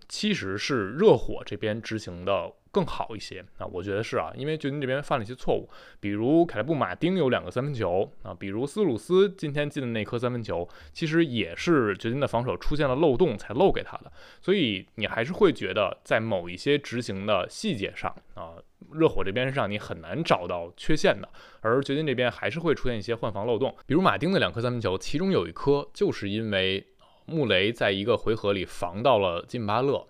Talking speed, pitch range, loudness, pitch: 320 characters per minute, 100-145 Hz, -27 LUFS, 120 Hz